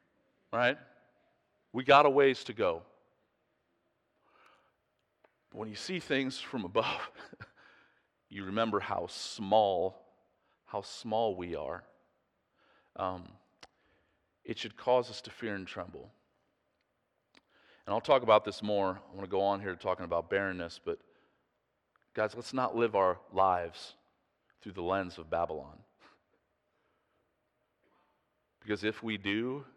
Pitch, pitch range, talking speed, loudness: 105 Hz, 95-120 Hz, 125 wpm, -32 LUFS